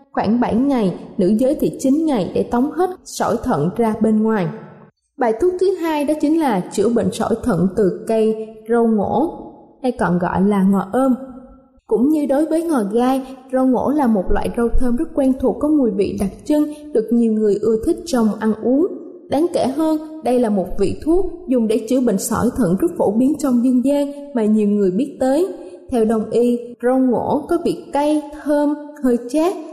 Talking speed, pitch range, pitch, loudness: 205 wpm, 220-290 Hz, 250 Hz, -18 LUFS